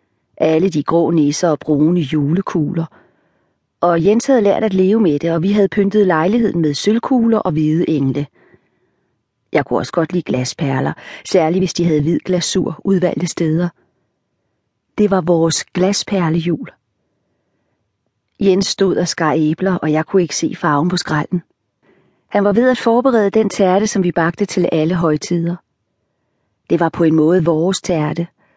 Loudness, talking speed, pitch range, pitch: -16 LUFS, 160 wpm, 150-190 Hz, 170 Hz